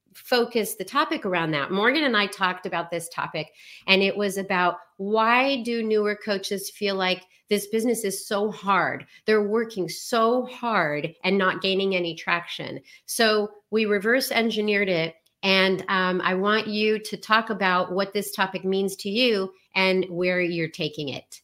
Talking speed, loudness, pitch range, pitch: 170 wpm, -24 LUFS, 185-215 Hz, 195 Hz